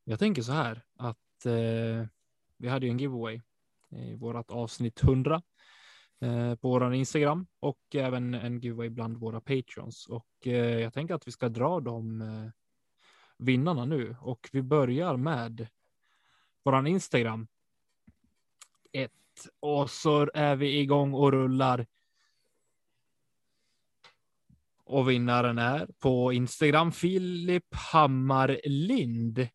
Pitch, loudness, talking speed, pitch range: 125 Hz, -29 LUFS, 120 wpm, 115-145 Hz